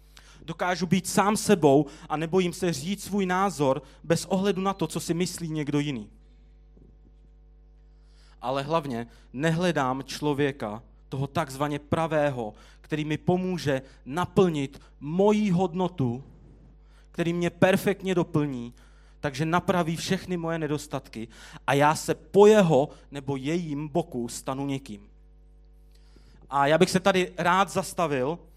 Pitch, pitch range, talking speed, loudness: 150 Hz, 135-180 Hz, 120 wpm, -26 LUFS